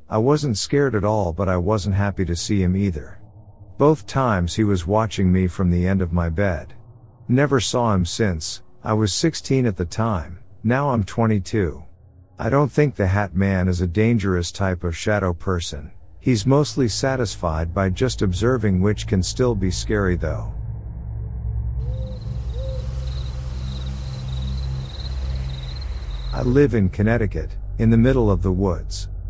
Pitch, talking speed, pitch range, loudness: 100 Hz, 150 wpm, 85-110 Hz, -21 LUFS